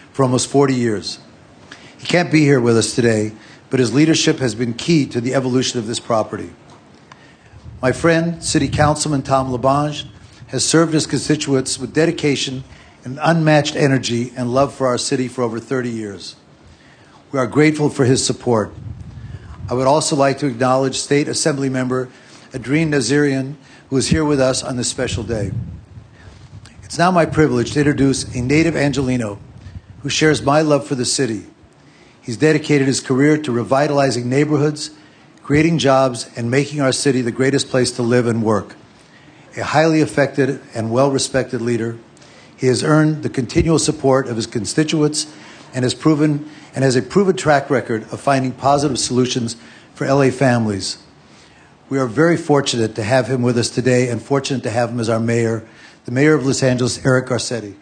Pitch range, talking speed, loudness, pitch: 120-145 Hz, 170 wpm, -17 LUFS, 130 Hz